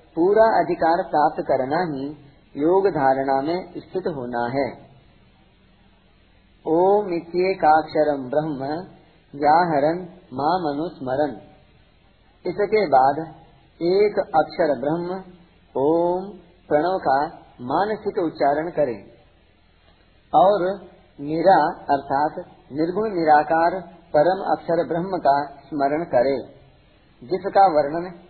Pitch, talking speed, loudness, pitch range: 160 Hz, 85 wpm, -21 LUFS, 140-180 Hz